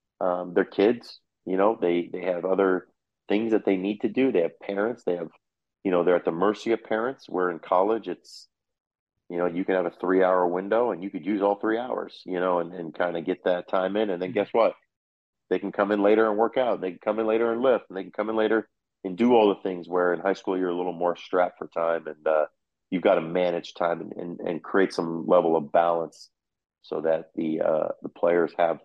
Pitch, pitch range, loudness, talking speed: 90 Hz, 85-100 Hz, -25 LUFS, 255 wpm